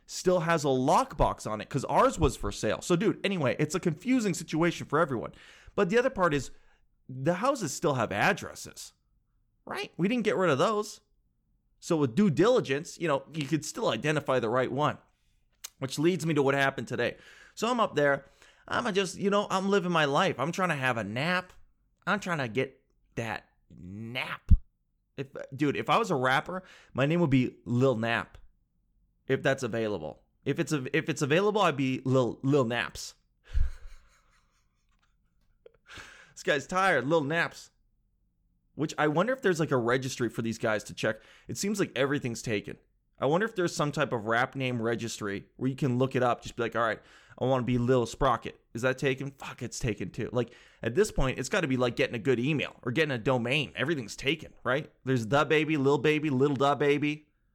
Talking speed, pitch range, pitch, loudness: 200 wpm, 120-165 Hz, 140 Hz, -29 LUFS